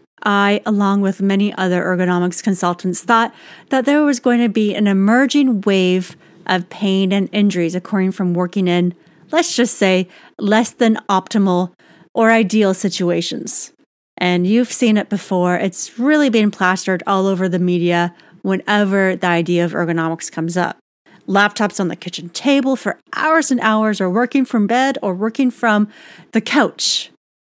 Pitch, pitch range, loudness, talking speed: 200 Hz, 180-225 Hz, -16 LUFS, 155 wpm